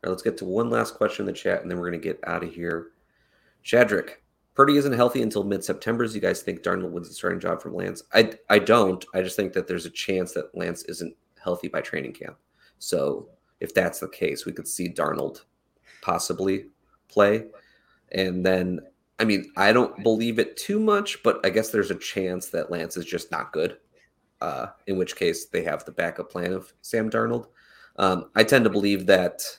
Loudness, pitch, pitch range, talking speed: -25 LUFS, 100 Hz, 95-120 Hz, 215 wpm